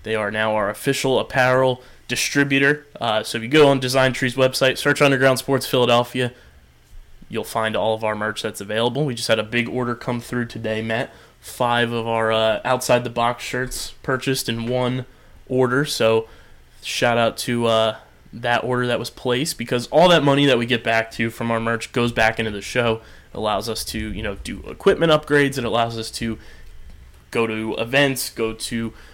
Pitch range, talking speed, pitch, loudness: 110-130 Hz, 200 wpm, 120 Hz, -20 LUFS